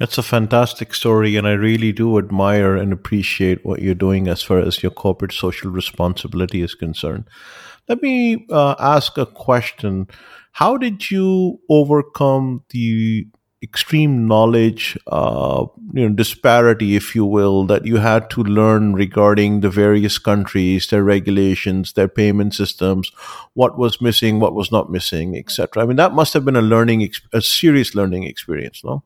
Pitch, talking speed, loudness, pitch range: 105 Hz, 165 wpm, -16 LUFS, 95-120 Hz